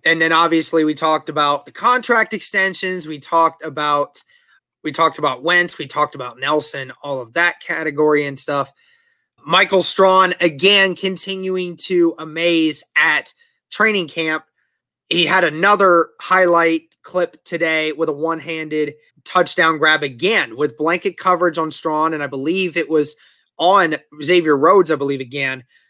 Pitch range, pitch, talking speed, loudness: 150-185 Hz, 165 Hz, 150 wpm, -17 LUFS